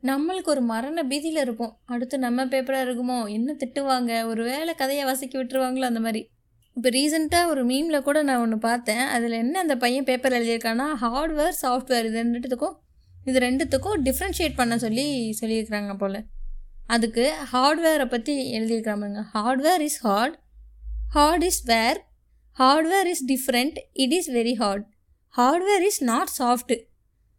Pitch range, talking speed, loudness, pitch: 230-290 Hz, 140 wpm, -24 LUFS, 255 Hz